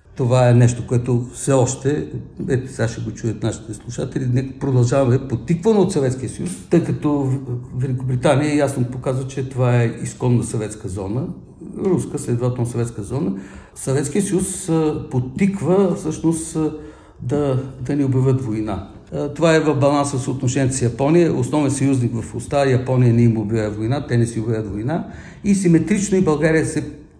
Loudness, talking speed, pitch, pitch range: -19 LUFS, 155 wpm, 130 Hz, 120-150 Hz